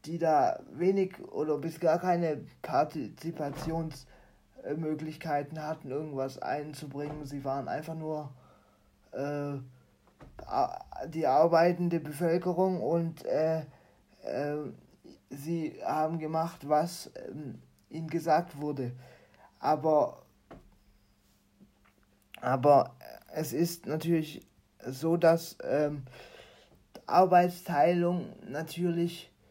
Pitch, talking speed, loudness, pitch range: 155 Hz, 80 wpm, -31 LUFS, 145-170 Hz